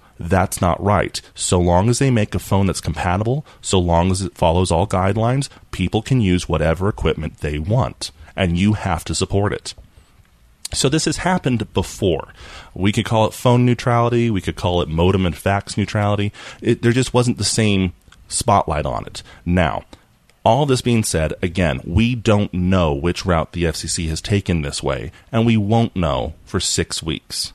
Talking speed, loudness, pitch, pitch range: 185 wpm, -19 LUFS, 95 Hz, 85-115 Hz